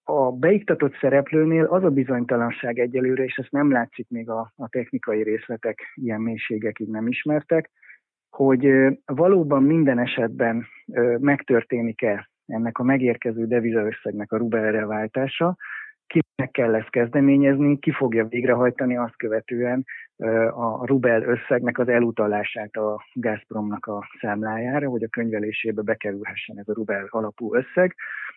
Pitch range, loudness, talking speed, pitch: 110-135 Hz, -23 LUFS, 125 wpm, 120 Hz